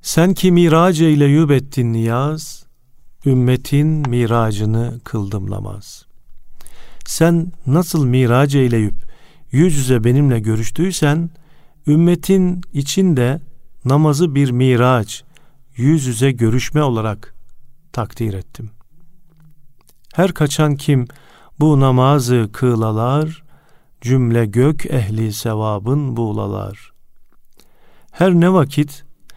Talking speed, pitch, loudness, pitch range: 85 wpm, 135 Hz, -16 LUFS, 120-155 Hz